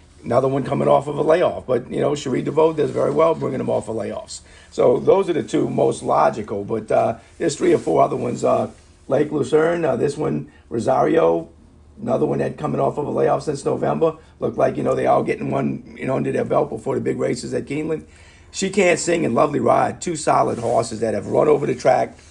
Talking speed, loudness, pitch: 230 wpm, -20 LUFS, 135 Hz